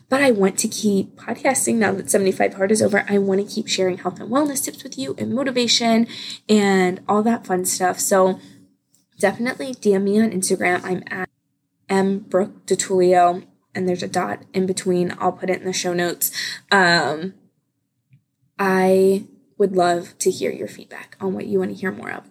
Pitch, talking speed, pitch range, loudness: 190 Hz, 185 wpm, 180-215 Hz, -20 LUFS